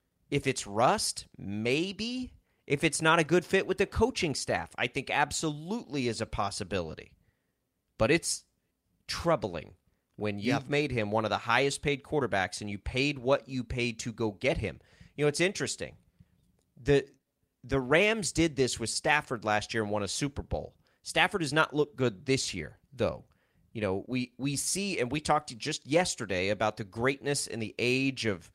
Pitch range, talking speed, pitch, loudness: 105-150 Hz, 185 wpm, 130 Hz, -30 LUFS